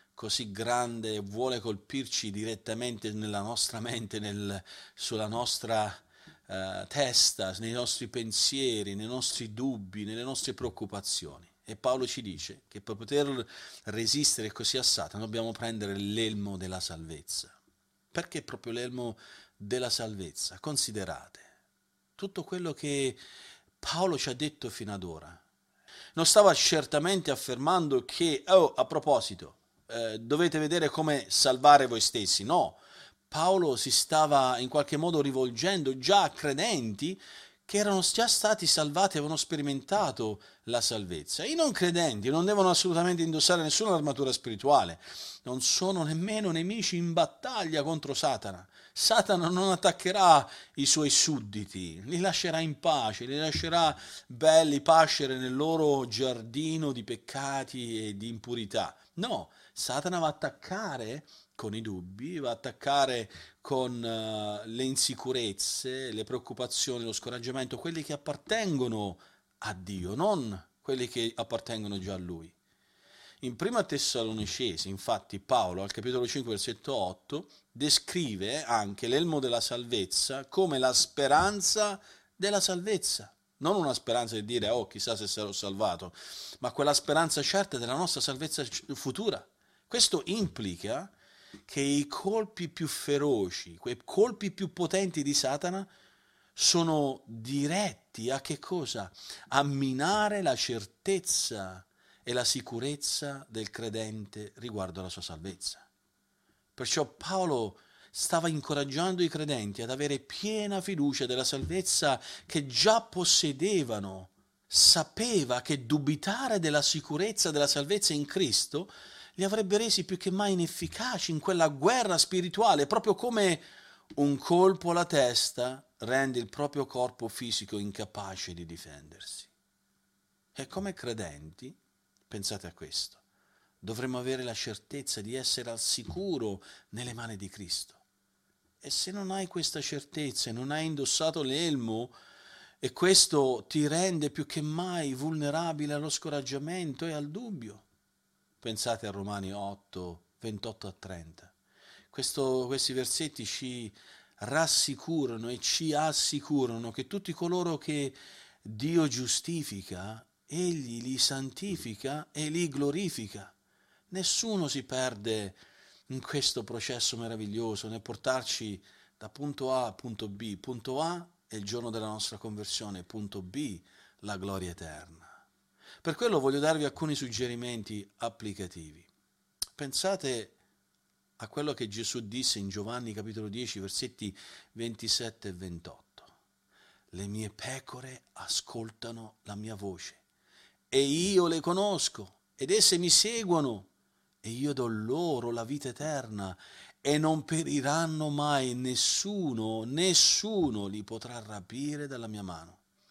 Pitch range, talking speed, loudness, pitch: 110-160 Hz, 125 wpm, -30 LUFS, 130 Hz